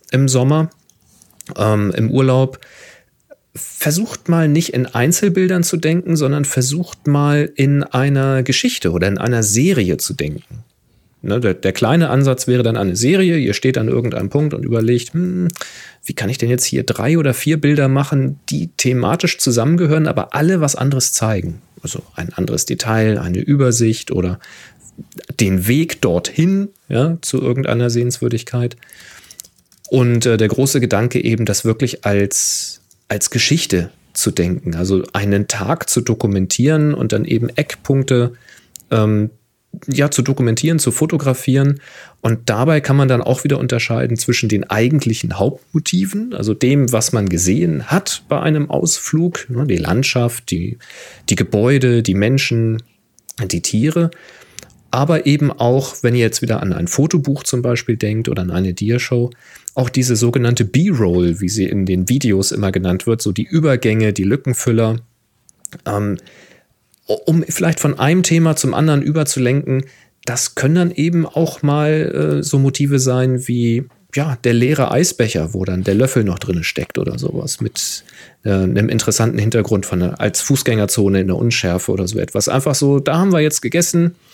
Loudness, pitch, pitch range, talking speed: -16 LUFS, 125 Hz, 110-145 Hz, 160 wpm